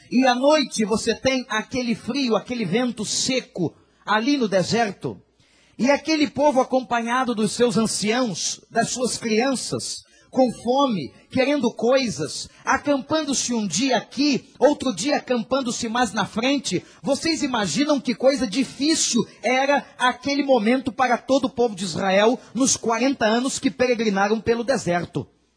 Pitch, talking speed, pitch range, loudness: 245 Hz, 135 wpm, 215-265 Hz, -22 LUFS